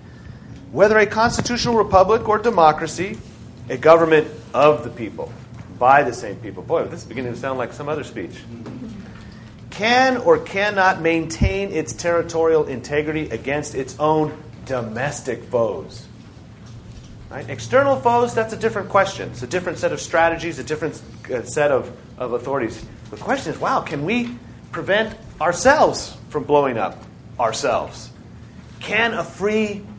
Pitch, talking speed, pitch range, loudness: 150 Hz, 140 wpm, 120-190 Hz, -19 LUFS